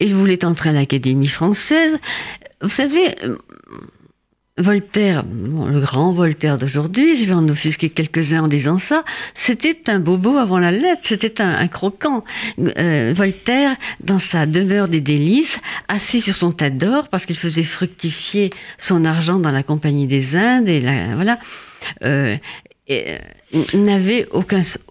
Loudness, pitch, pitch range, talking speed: -17 LUFS, 180 Hz, 155-215 Hz, 150 wpm